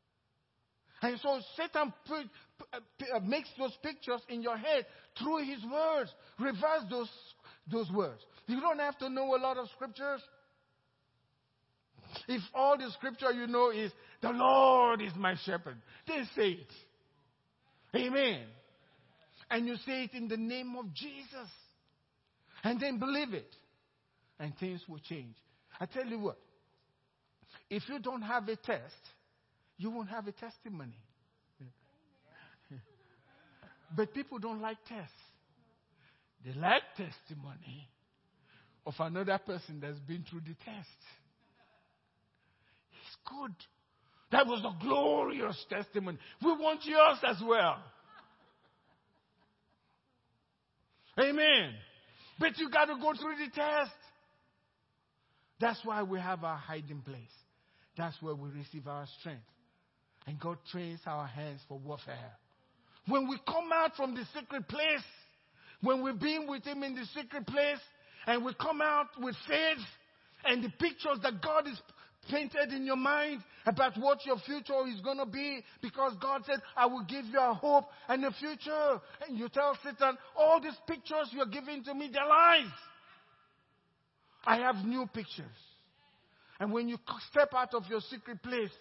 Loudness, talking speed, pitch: -33 LUFS, 145 wpm, 240 Hz